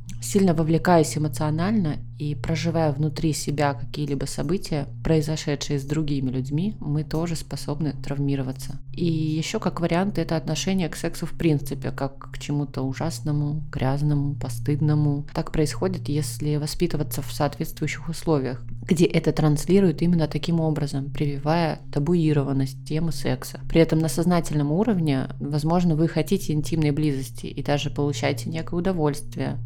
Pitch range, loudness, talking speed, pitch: 140-160 Hz, -24 LUFS, 130 wpm, 150 Hz